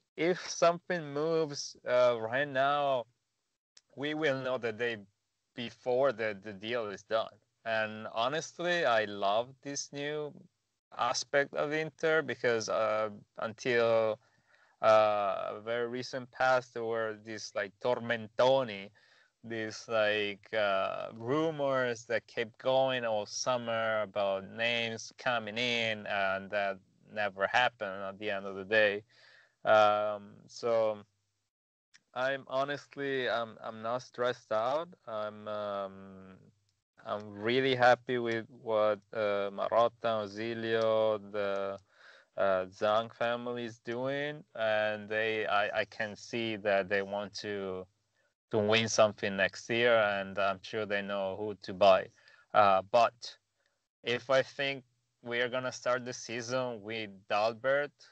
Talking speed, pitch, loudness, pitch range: 125 wpm, 115 Hz, -32 LUFS, 105-125 Hz